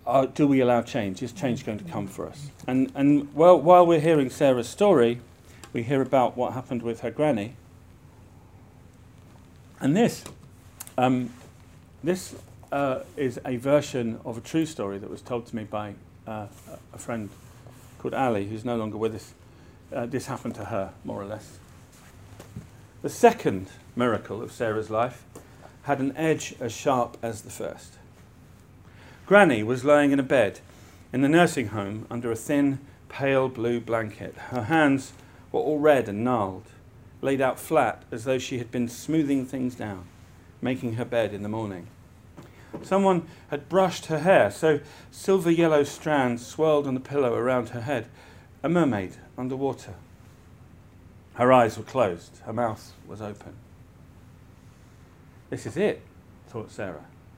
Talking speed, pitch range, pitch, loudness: 155 wpm, 105-135 Hz, 120 Hz, -25 LUFS